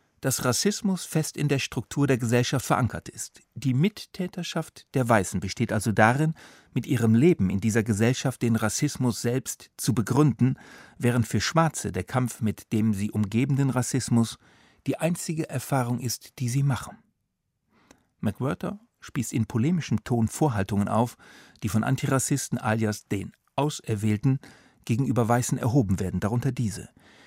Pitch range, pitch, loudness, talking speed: 110-140 Hz, 125 Hz, -26 LUFS, 140 wpm